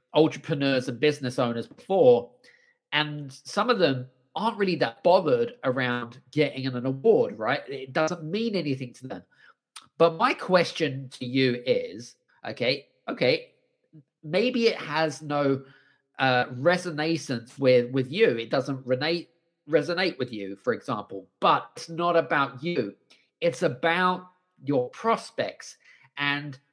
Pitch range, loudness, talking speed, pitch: 130-180 Hz, -26 LUFS, 130 wpm, 150 Hz